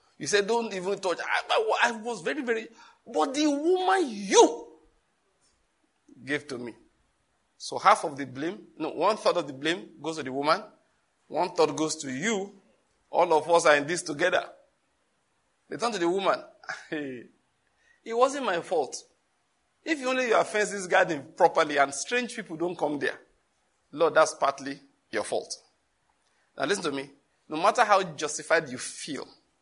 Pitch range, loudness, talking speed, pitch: 150-230 Hz, -27 LUFS, 160 wpm, 180 Hz